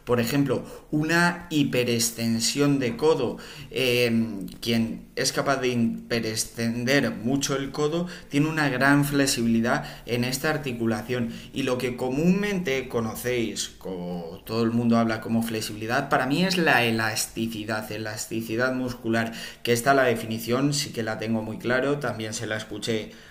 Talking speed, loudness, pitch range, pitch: 140 wpm, -25 LUFS, 115-140 Hz, 120 Hz